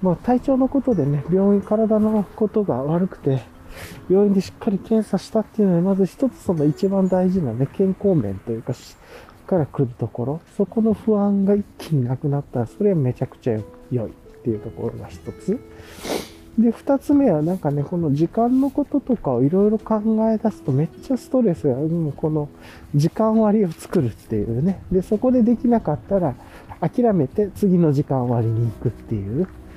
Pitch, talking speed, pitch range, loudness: 185 Hz, 350 characters per minute, 135-215 Hz, -21 LUFS